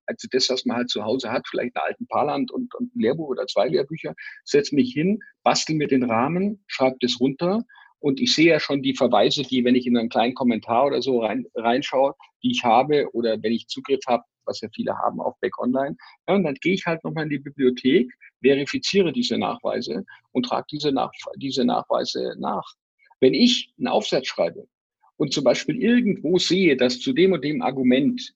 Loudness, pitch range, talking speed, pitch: -22 LUFS, 130-205 Hz, 205 wpm, 145 Hz